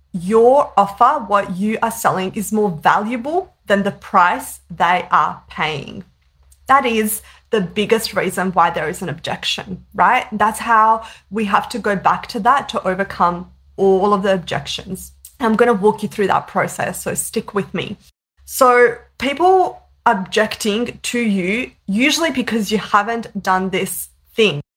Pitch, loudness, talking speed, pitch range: 210 Hz, -17 LUFS, 155 wpm, 185-230 Hz